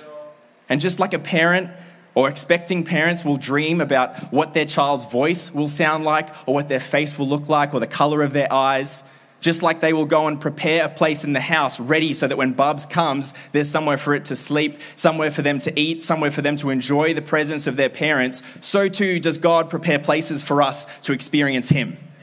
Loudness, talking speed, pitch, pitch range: -20 LUFS, 220 wpm, 150 Hz, 140-160 Hz